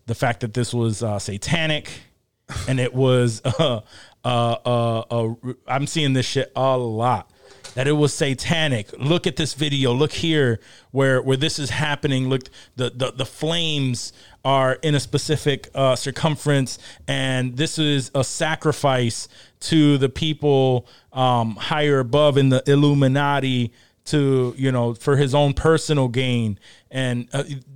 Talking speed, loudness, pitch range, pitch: 150 wpm, -21 LUFS, 125-145 Hz, 130 Hz